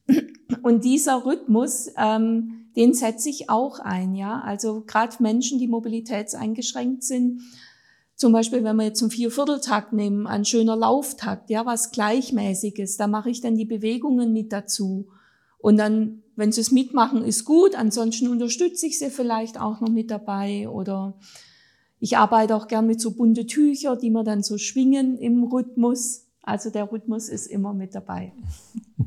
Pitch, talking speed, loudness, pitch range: 225 Hz, 160 wpm, -22 LUFS, 215-250 Hz